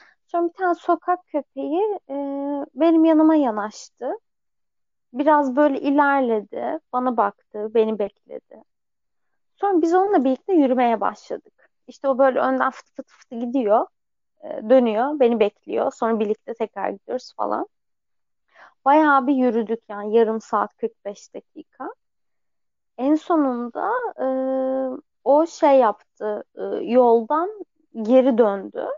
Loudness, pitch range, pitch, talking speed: -21 LUFS, 235-315 Hz, 270 Hz, 120 wpm